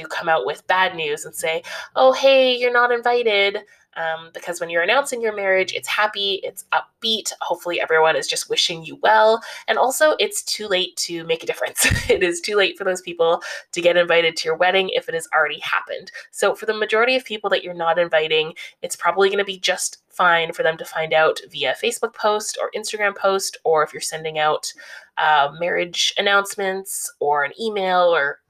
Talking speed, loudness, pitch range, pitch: 205 wpm, -19 LUFS, 170-245 Hz, 195 Hz